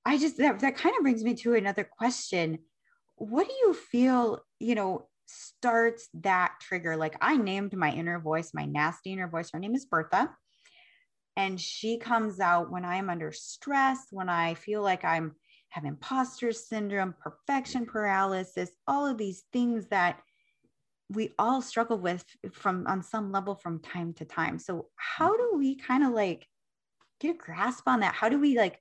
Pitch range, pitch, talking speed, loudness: 175-255 Hz, 210 Hz, 175 wpm, -29 LUFS